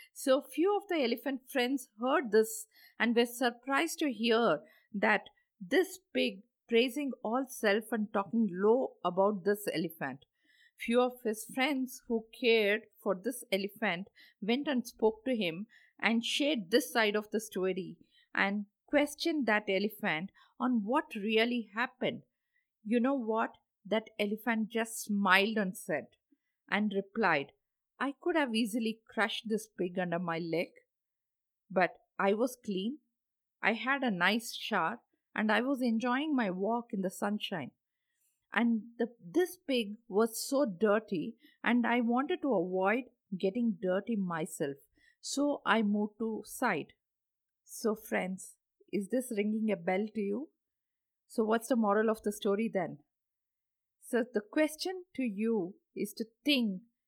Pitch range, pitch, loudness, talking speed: 205-260 Hz, 230 Hz, -33 LUFS, 145 wpm